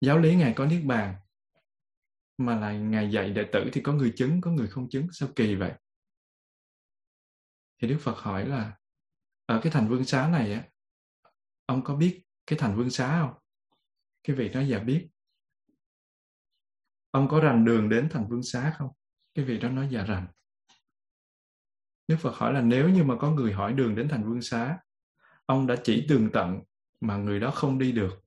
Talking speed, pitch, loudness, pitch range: 190 wpm, 120 Hz, -27 LUFS, 100-140 Hz